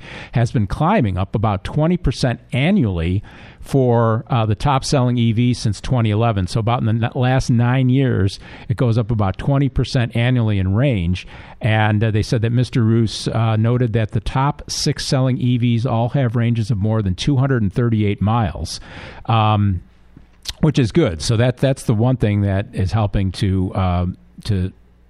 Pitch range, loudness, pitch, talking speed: 105-125 Hz, -18 LUFS, 115 Hz, 165 wpm